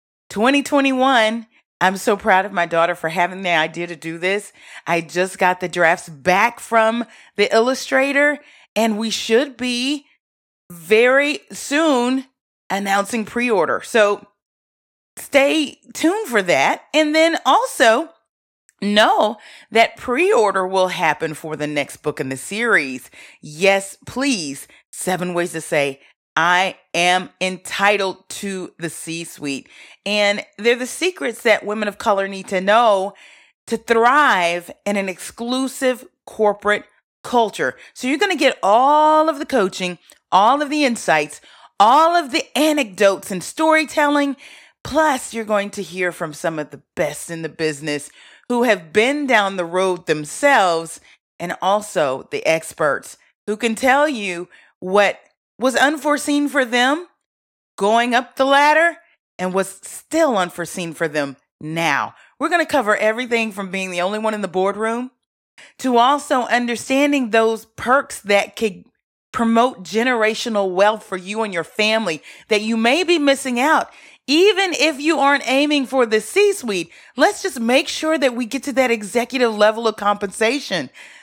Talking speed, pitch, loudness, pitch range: 150 wpm, 220 Hz, -18 LUFS, 185-270 Hz